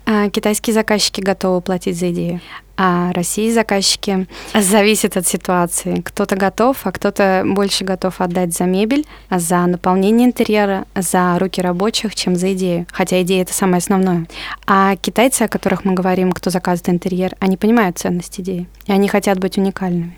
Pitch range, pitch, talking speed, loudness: 180-205 Hz, 190 Hz, 160 wpm, -16 LUFS